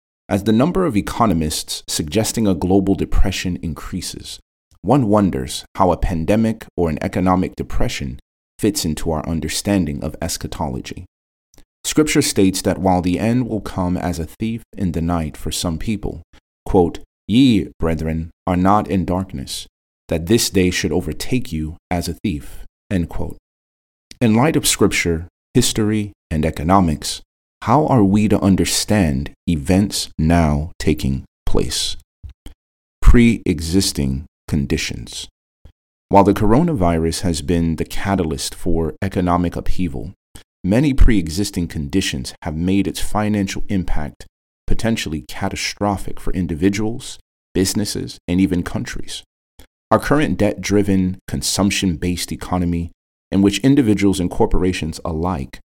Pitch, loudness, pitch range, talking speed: 90 Hz, -19 LUFS, 75-100 Hz, 130 wpm